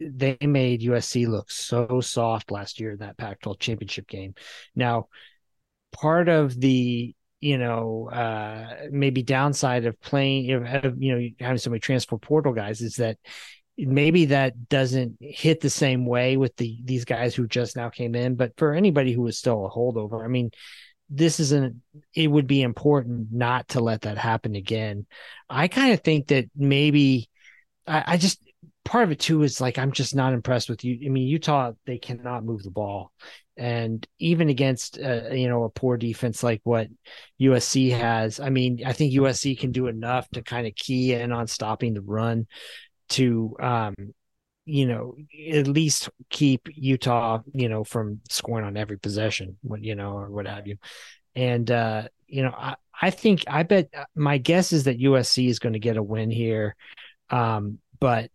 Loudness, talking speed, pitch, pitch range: -24 LUFS, 185 wpm, 125 Hz, 115-140 Hz